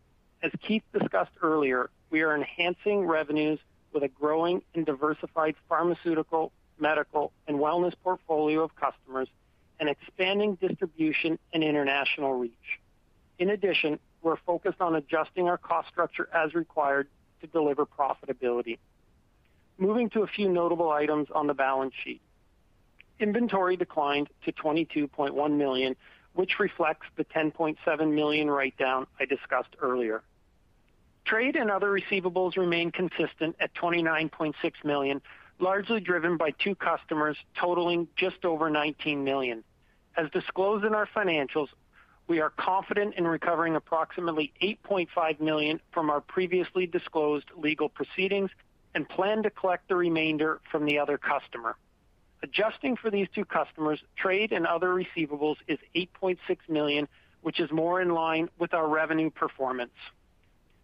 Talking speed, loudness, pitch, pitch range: 130 wpm, -29 LUFS, 160 Hz, 145-180 Hz